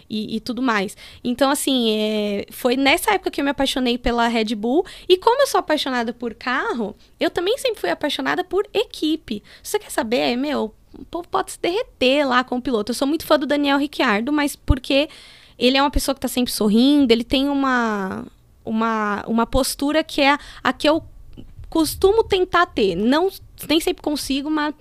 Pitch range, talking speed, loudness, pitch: 240-320 Hz, 200 wpm, -20 LUFS, 280 Hz